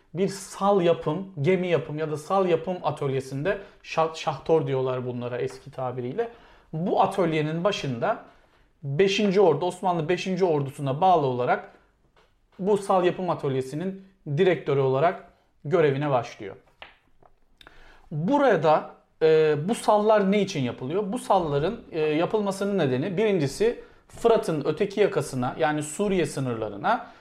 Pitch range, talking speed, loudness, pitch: 145-195 Hz, 115 wpm, -25 LUFS, 170 Hz